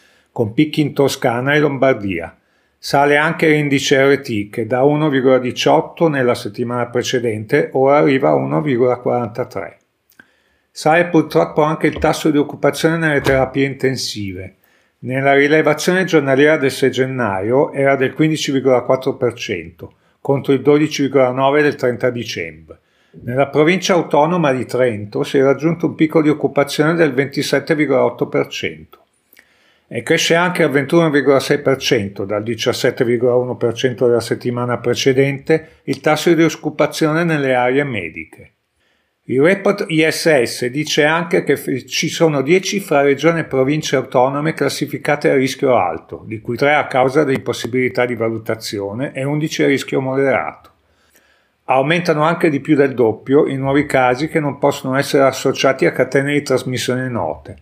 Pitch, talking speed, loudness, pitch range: 140 Hz, 130 wpm, -16 LUFS, 125-155 Hz